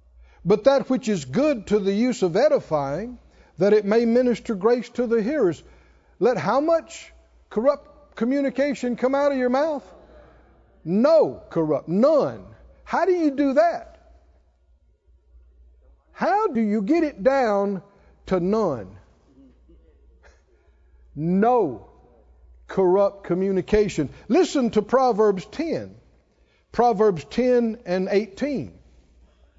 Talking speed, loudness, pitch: 110 wpm, -22 LUFS, 210 Hz